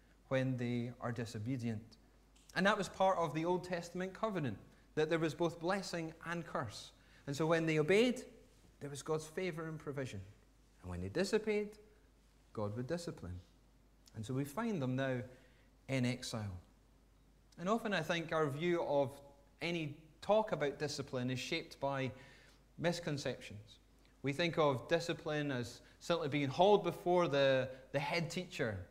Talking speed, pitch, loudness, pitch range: 155 wpm, 145 Hz, -38 LUFS, 125-170 Hz